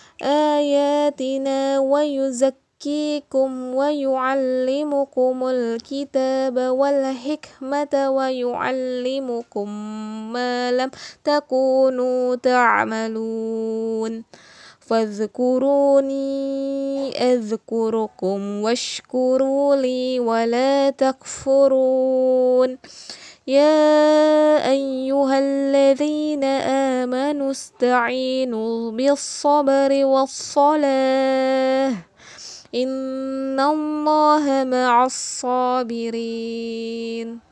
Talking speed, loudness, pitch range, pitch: 45 wpm, -20 LUFS, 245-275 Hz, 265 Hz